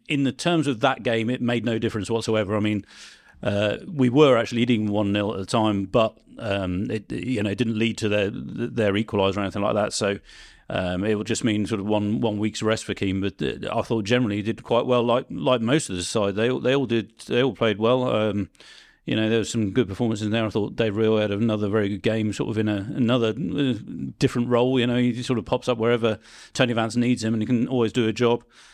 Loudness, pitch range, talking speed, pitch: -23 LUFS, 105-120 Hz, 250 wpm, 115 Hz